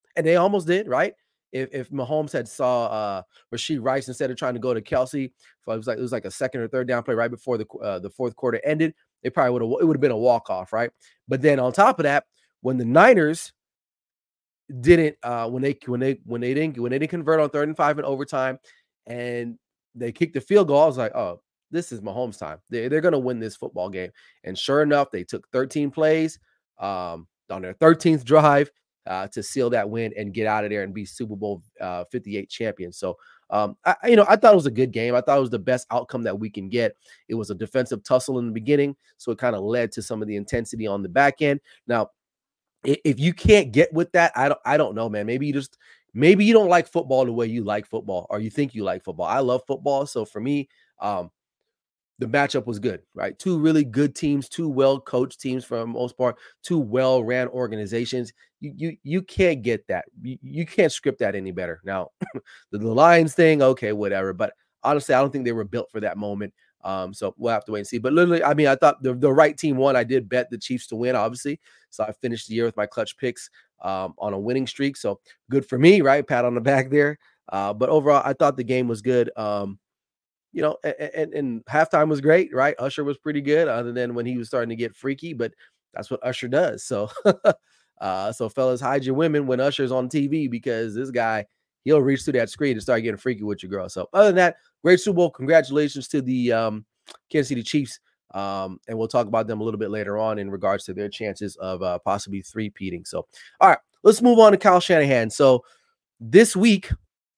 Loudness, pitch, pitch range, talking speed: -22 LUFS, 125 Hz, 115-145 Hz, 235 wpm